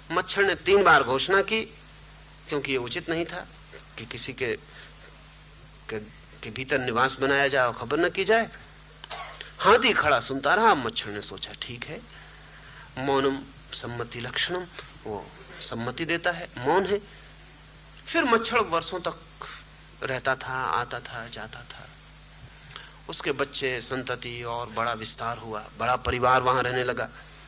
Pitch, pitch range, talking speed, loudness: 140 Hz, 125-175 Hz, 140 wpm, -26 LUFS